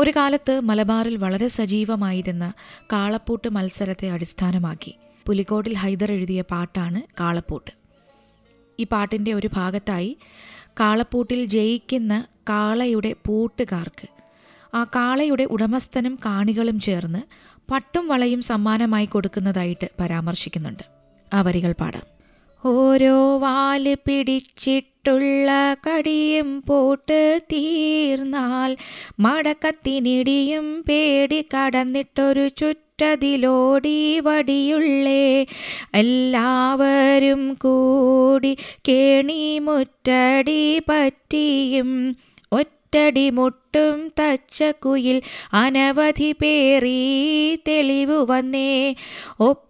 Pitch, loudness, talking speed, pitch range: 260 Hz, -20 LUFS, 65 wpm, 215-280 Hz